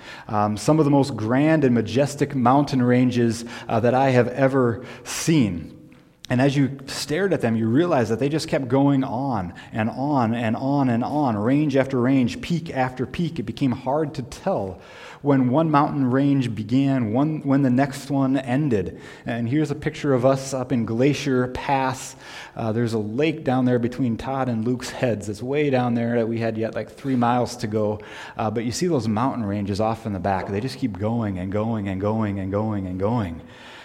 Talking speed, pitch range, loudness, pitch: 205 wpm, 115-135 Hz, -22 LUFS, 125 Hz